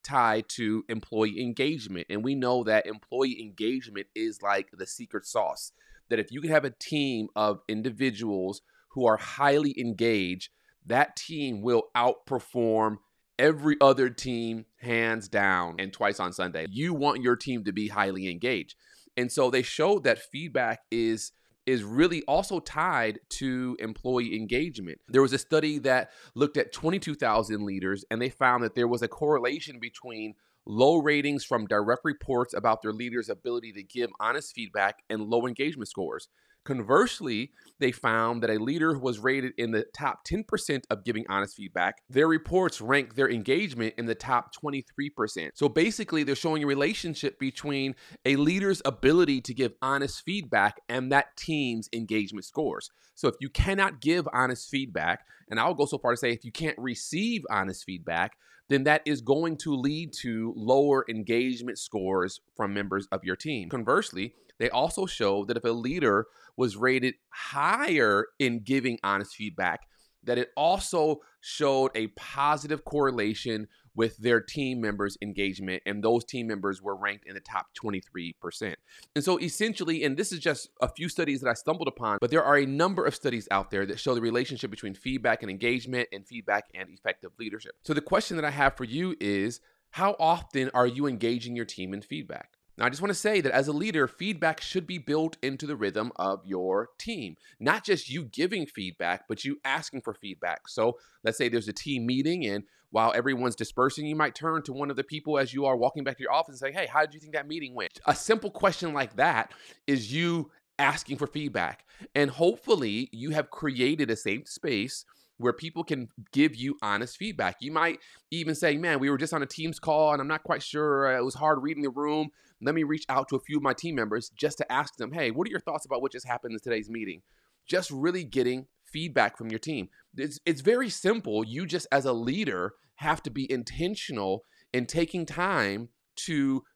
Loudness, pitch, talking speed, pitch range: -28 LUFS, 130 Hz, 190 wpm, 115-150 Hz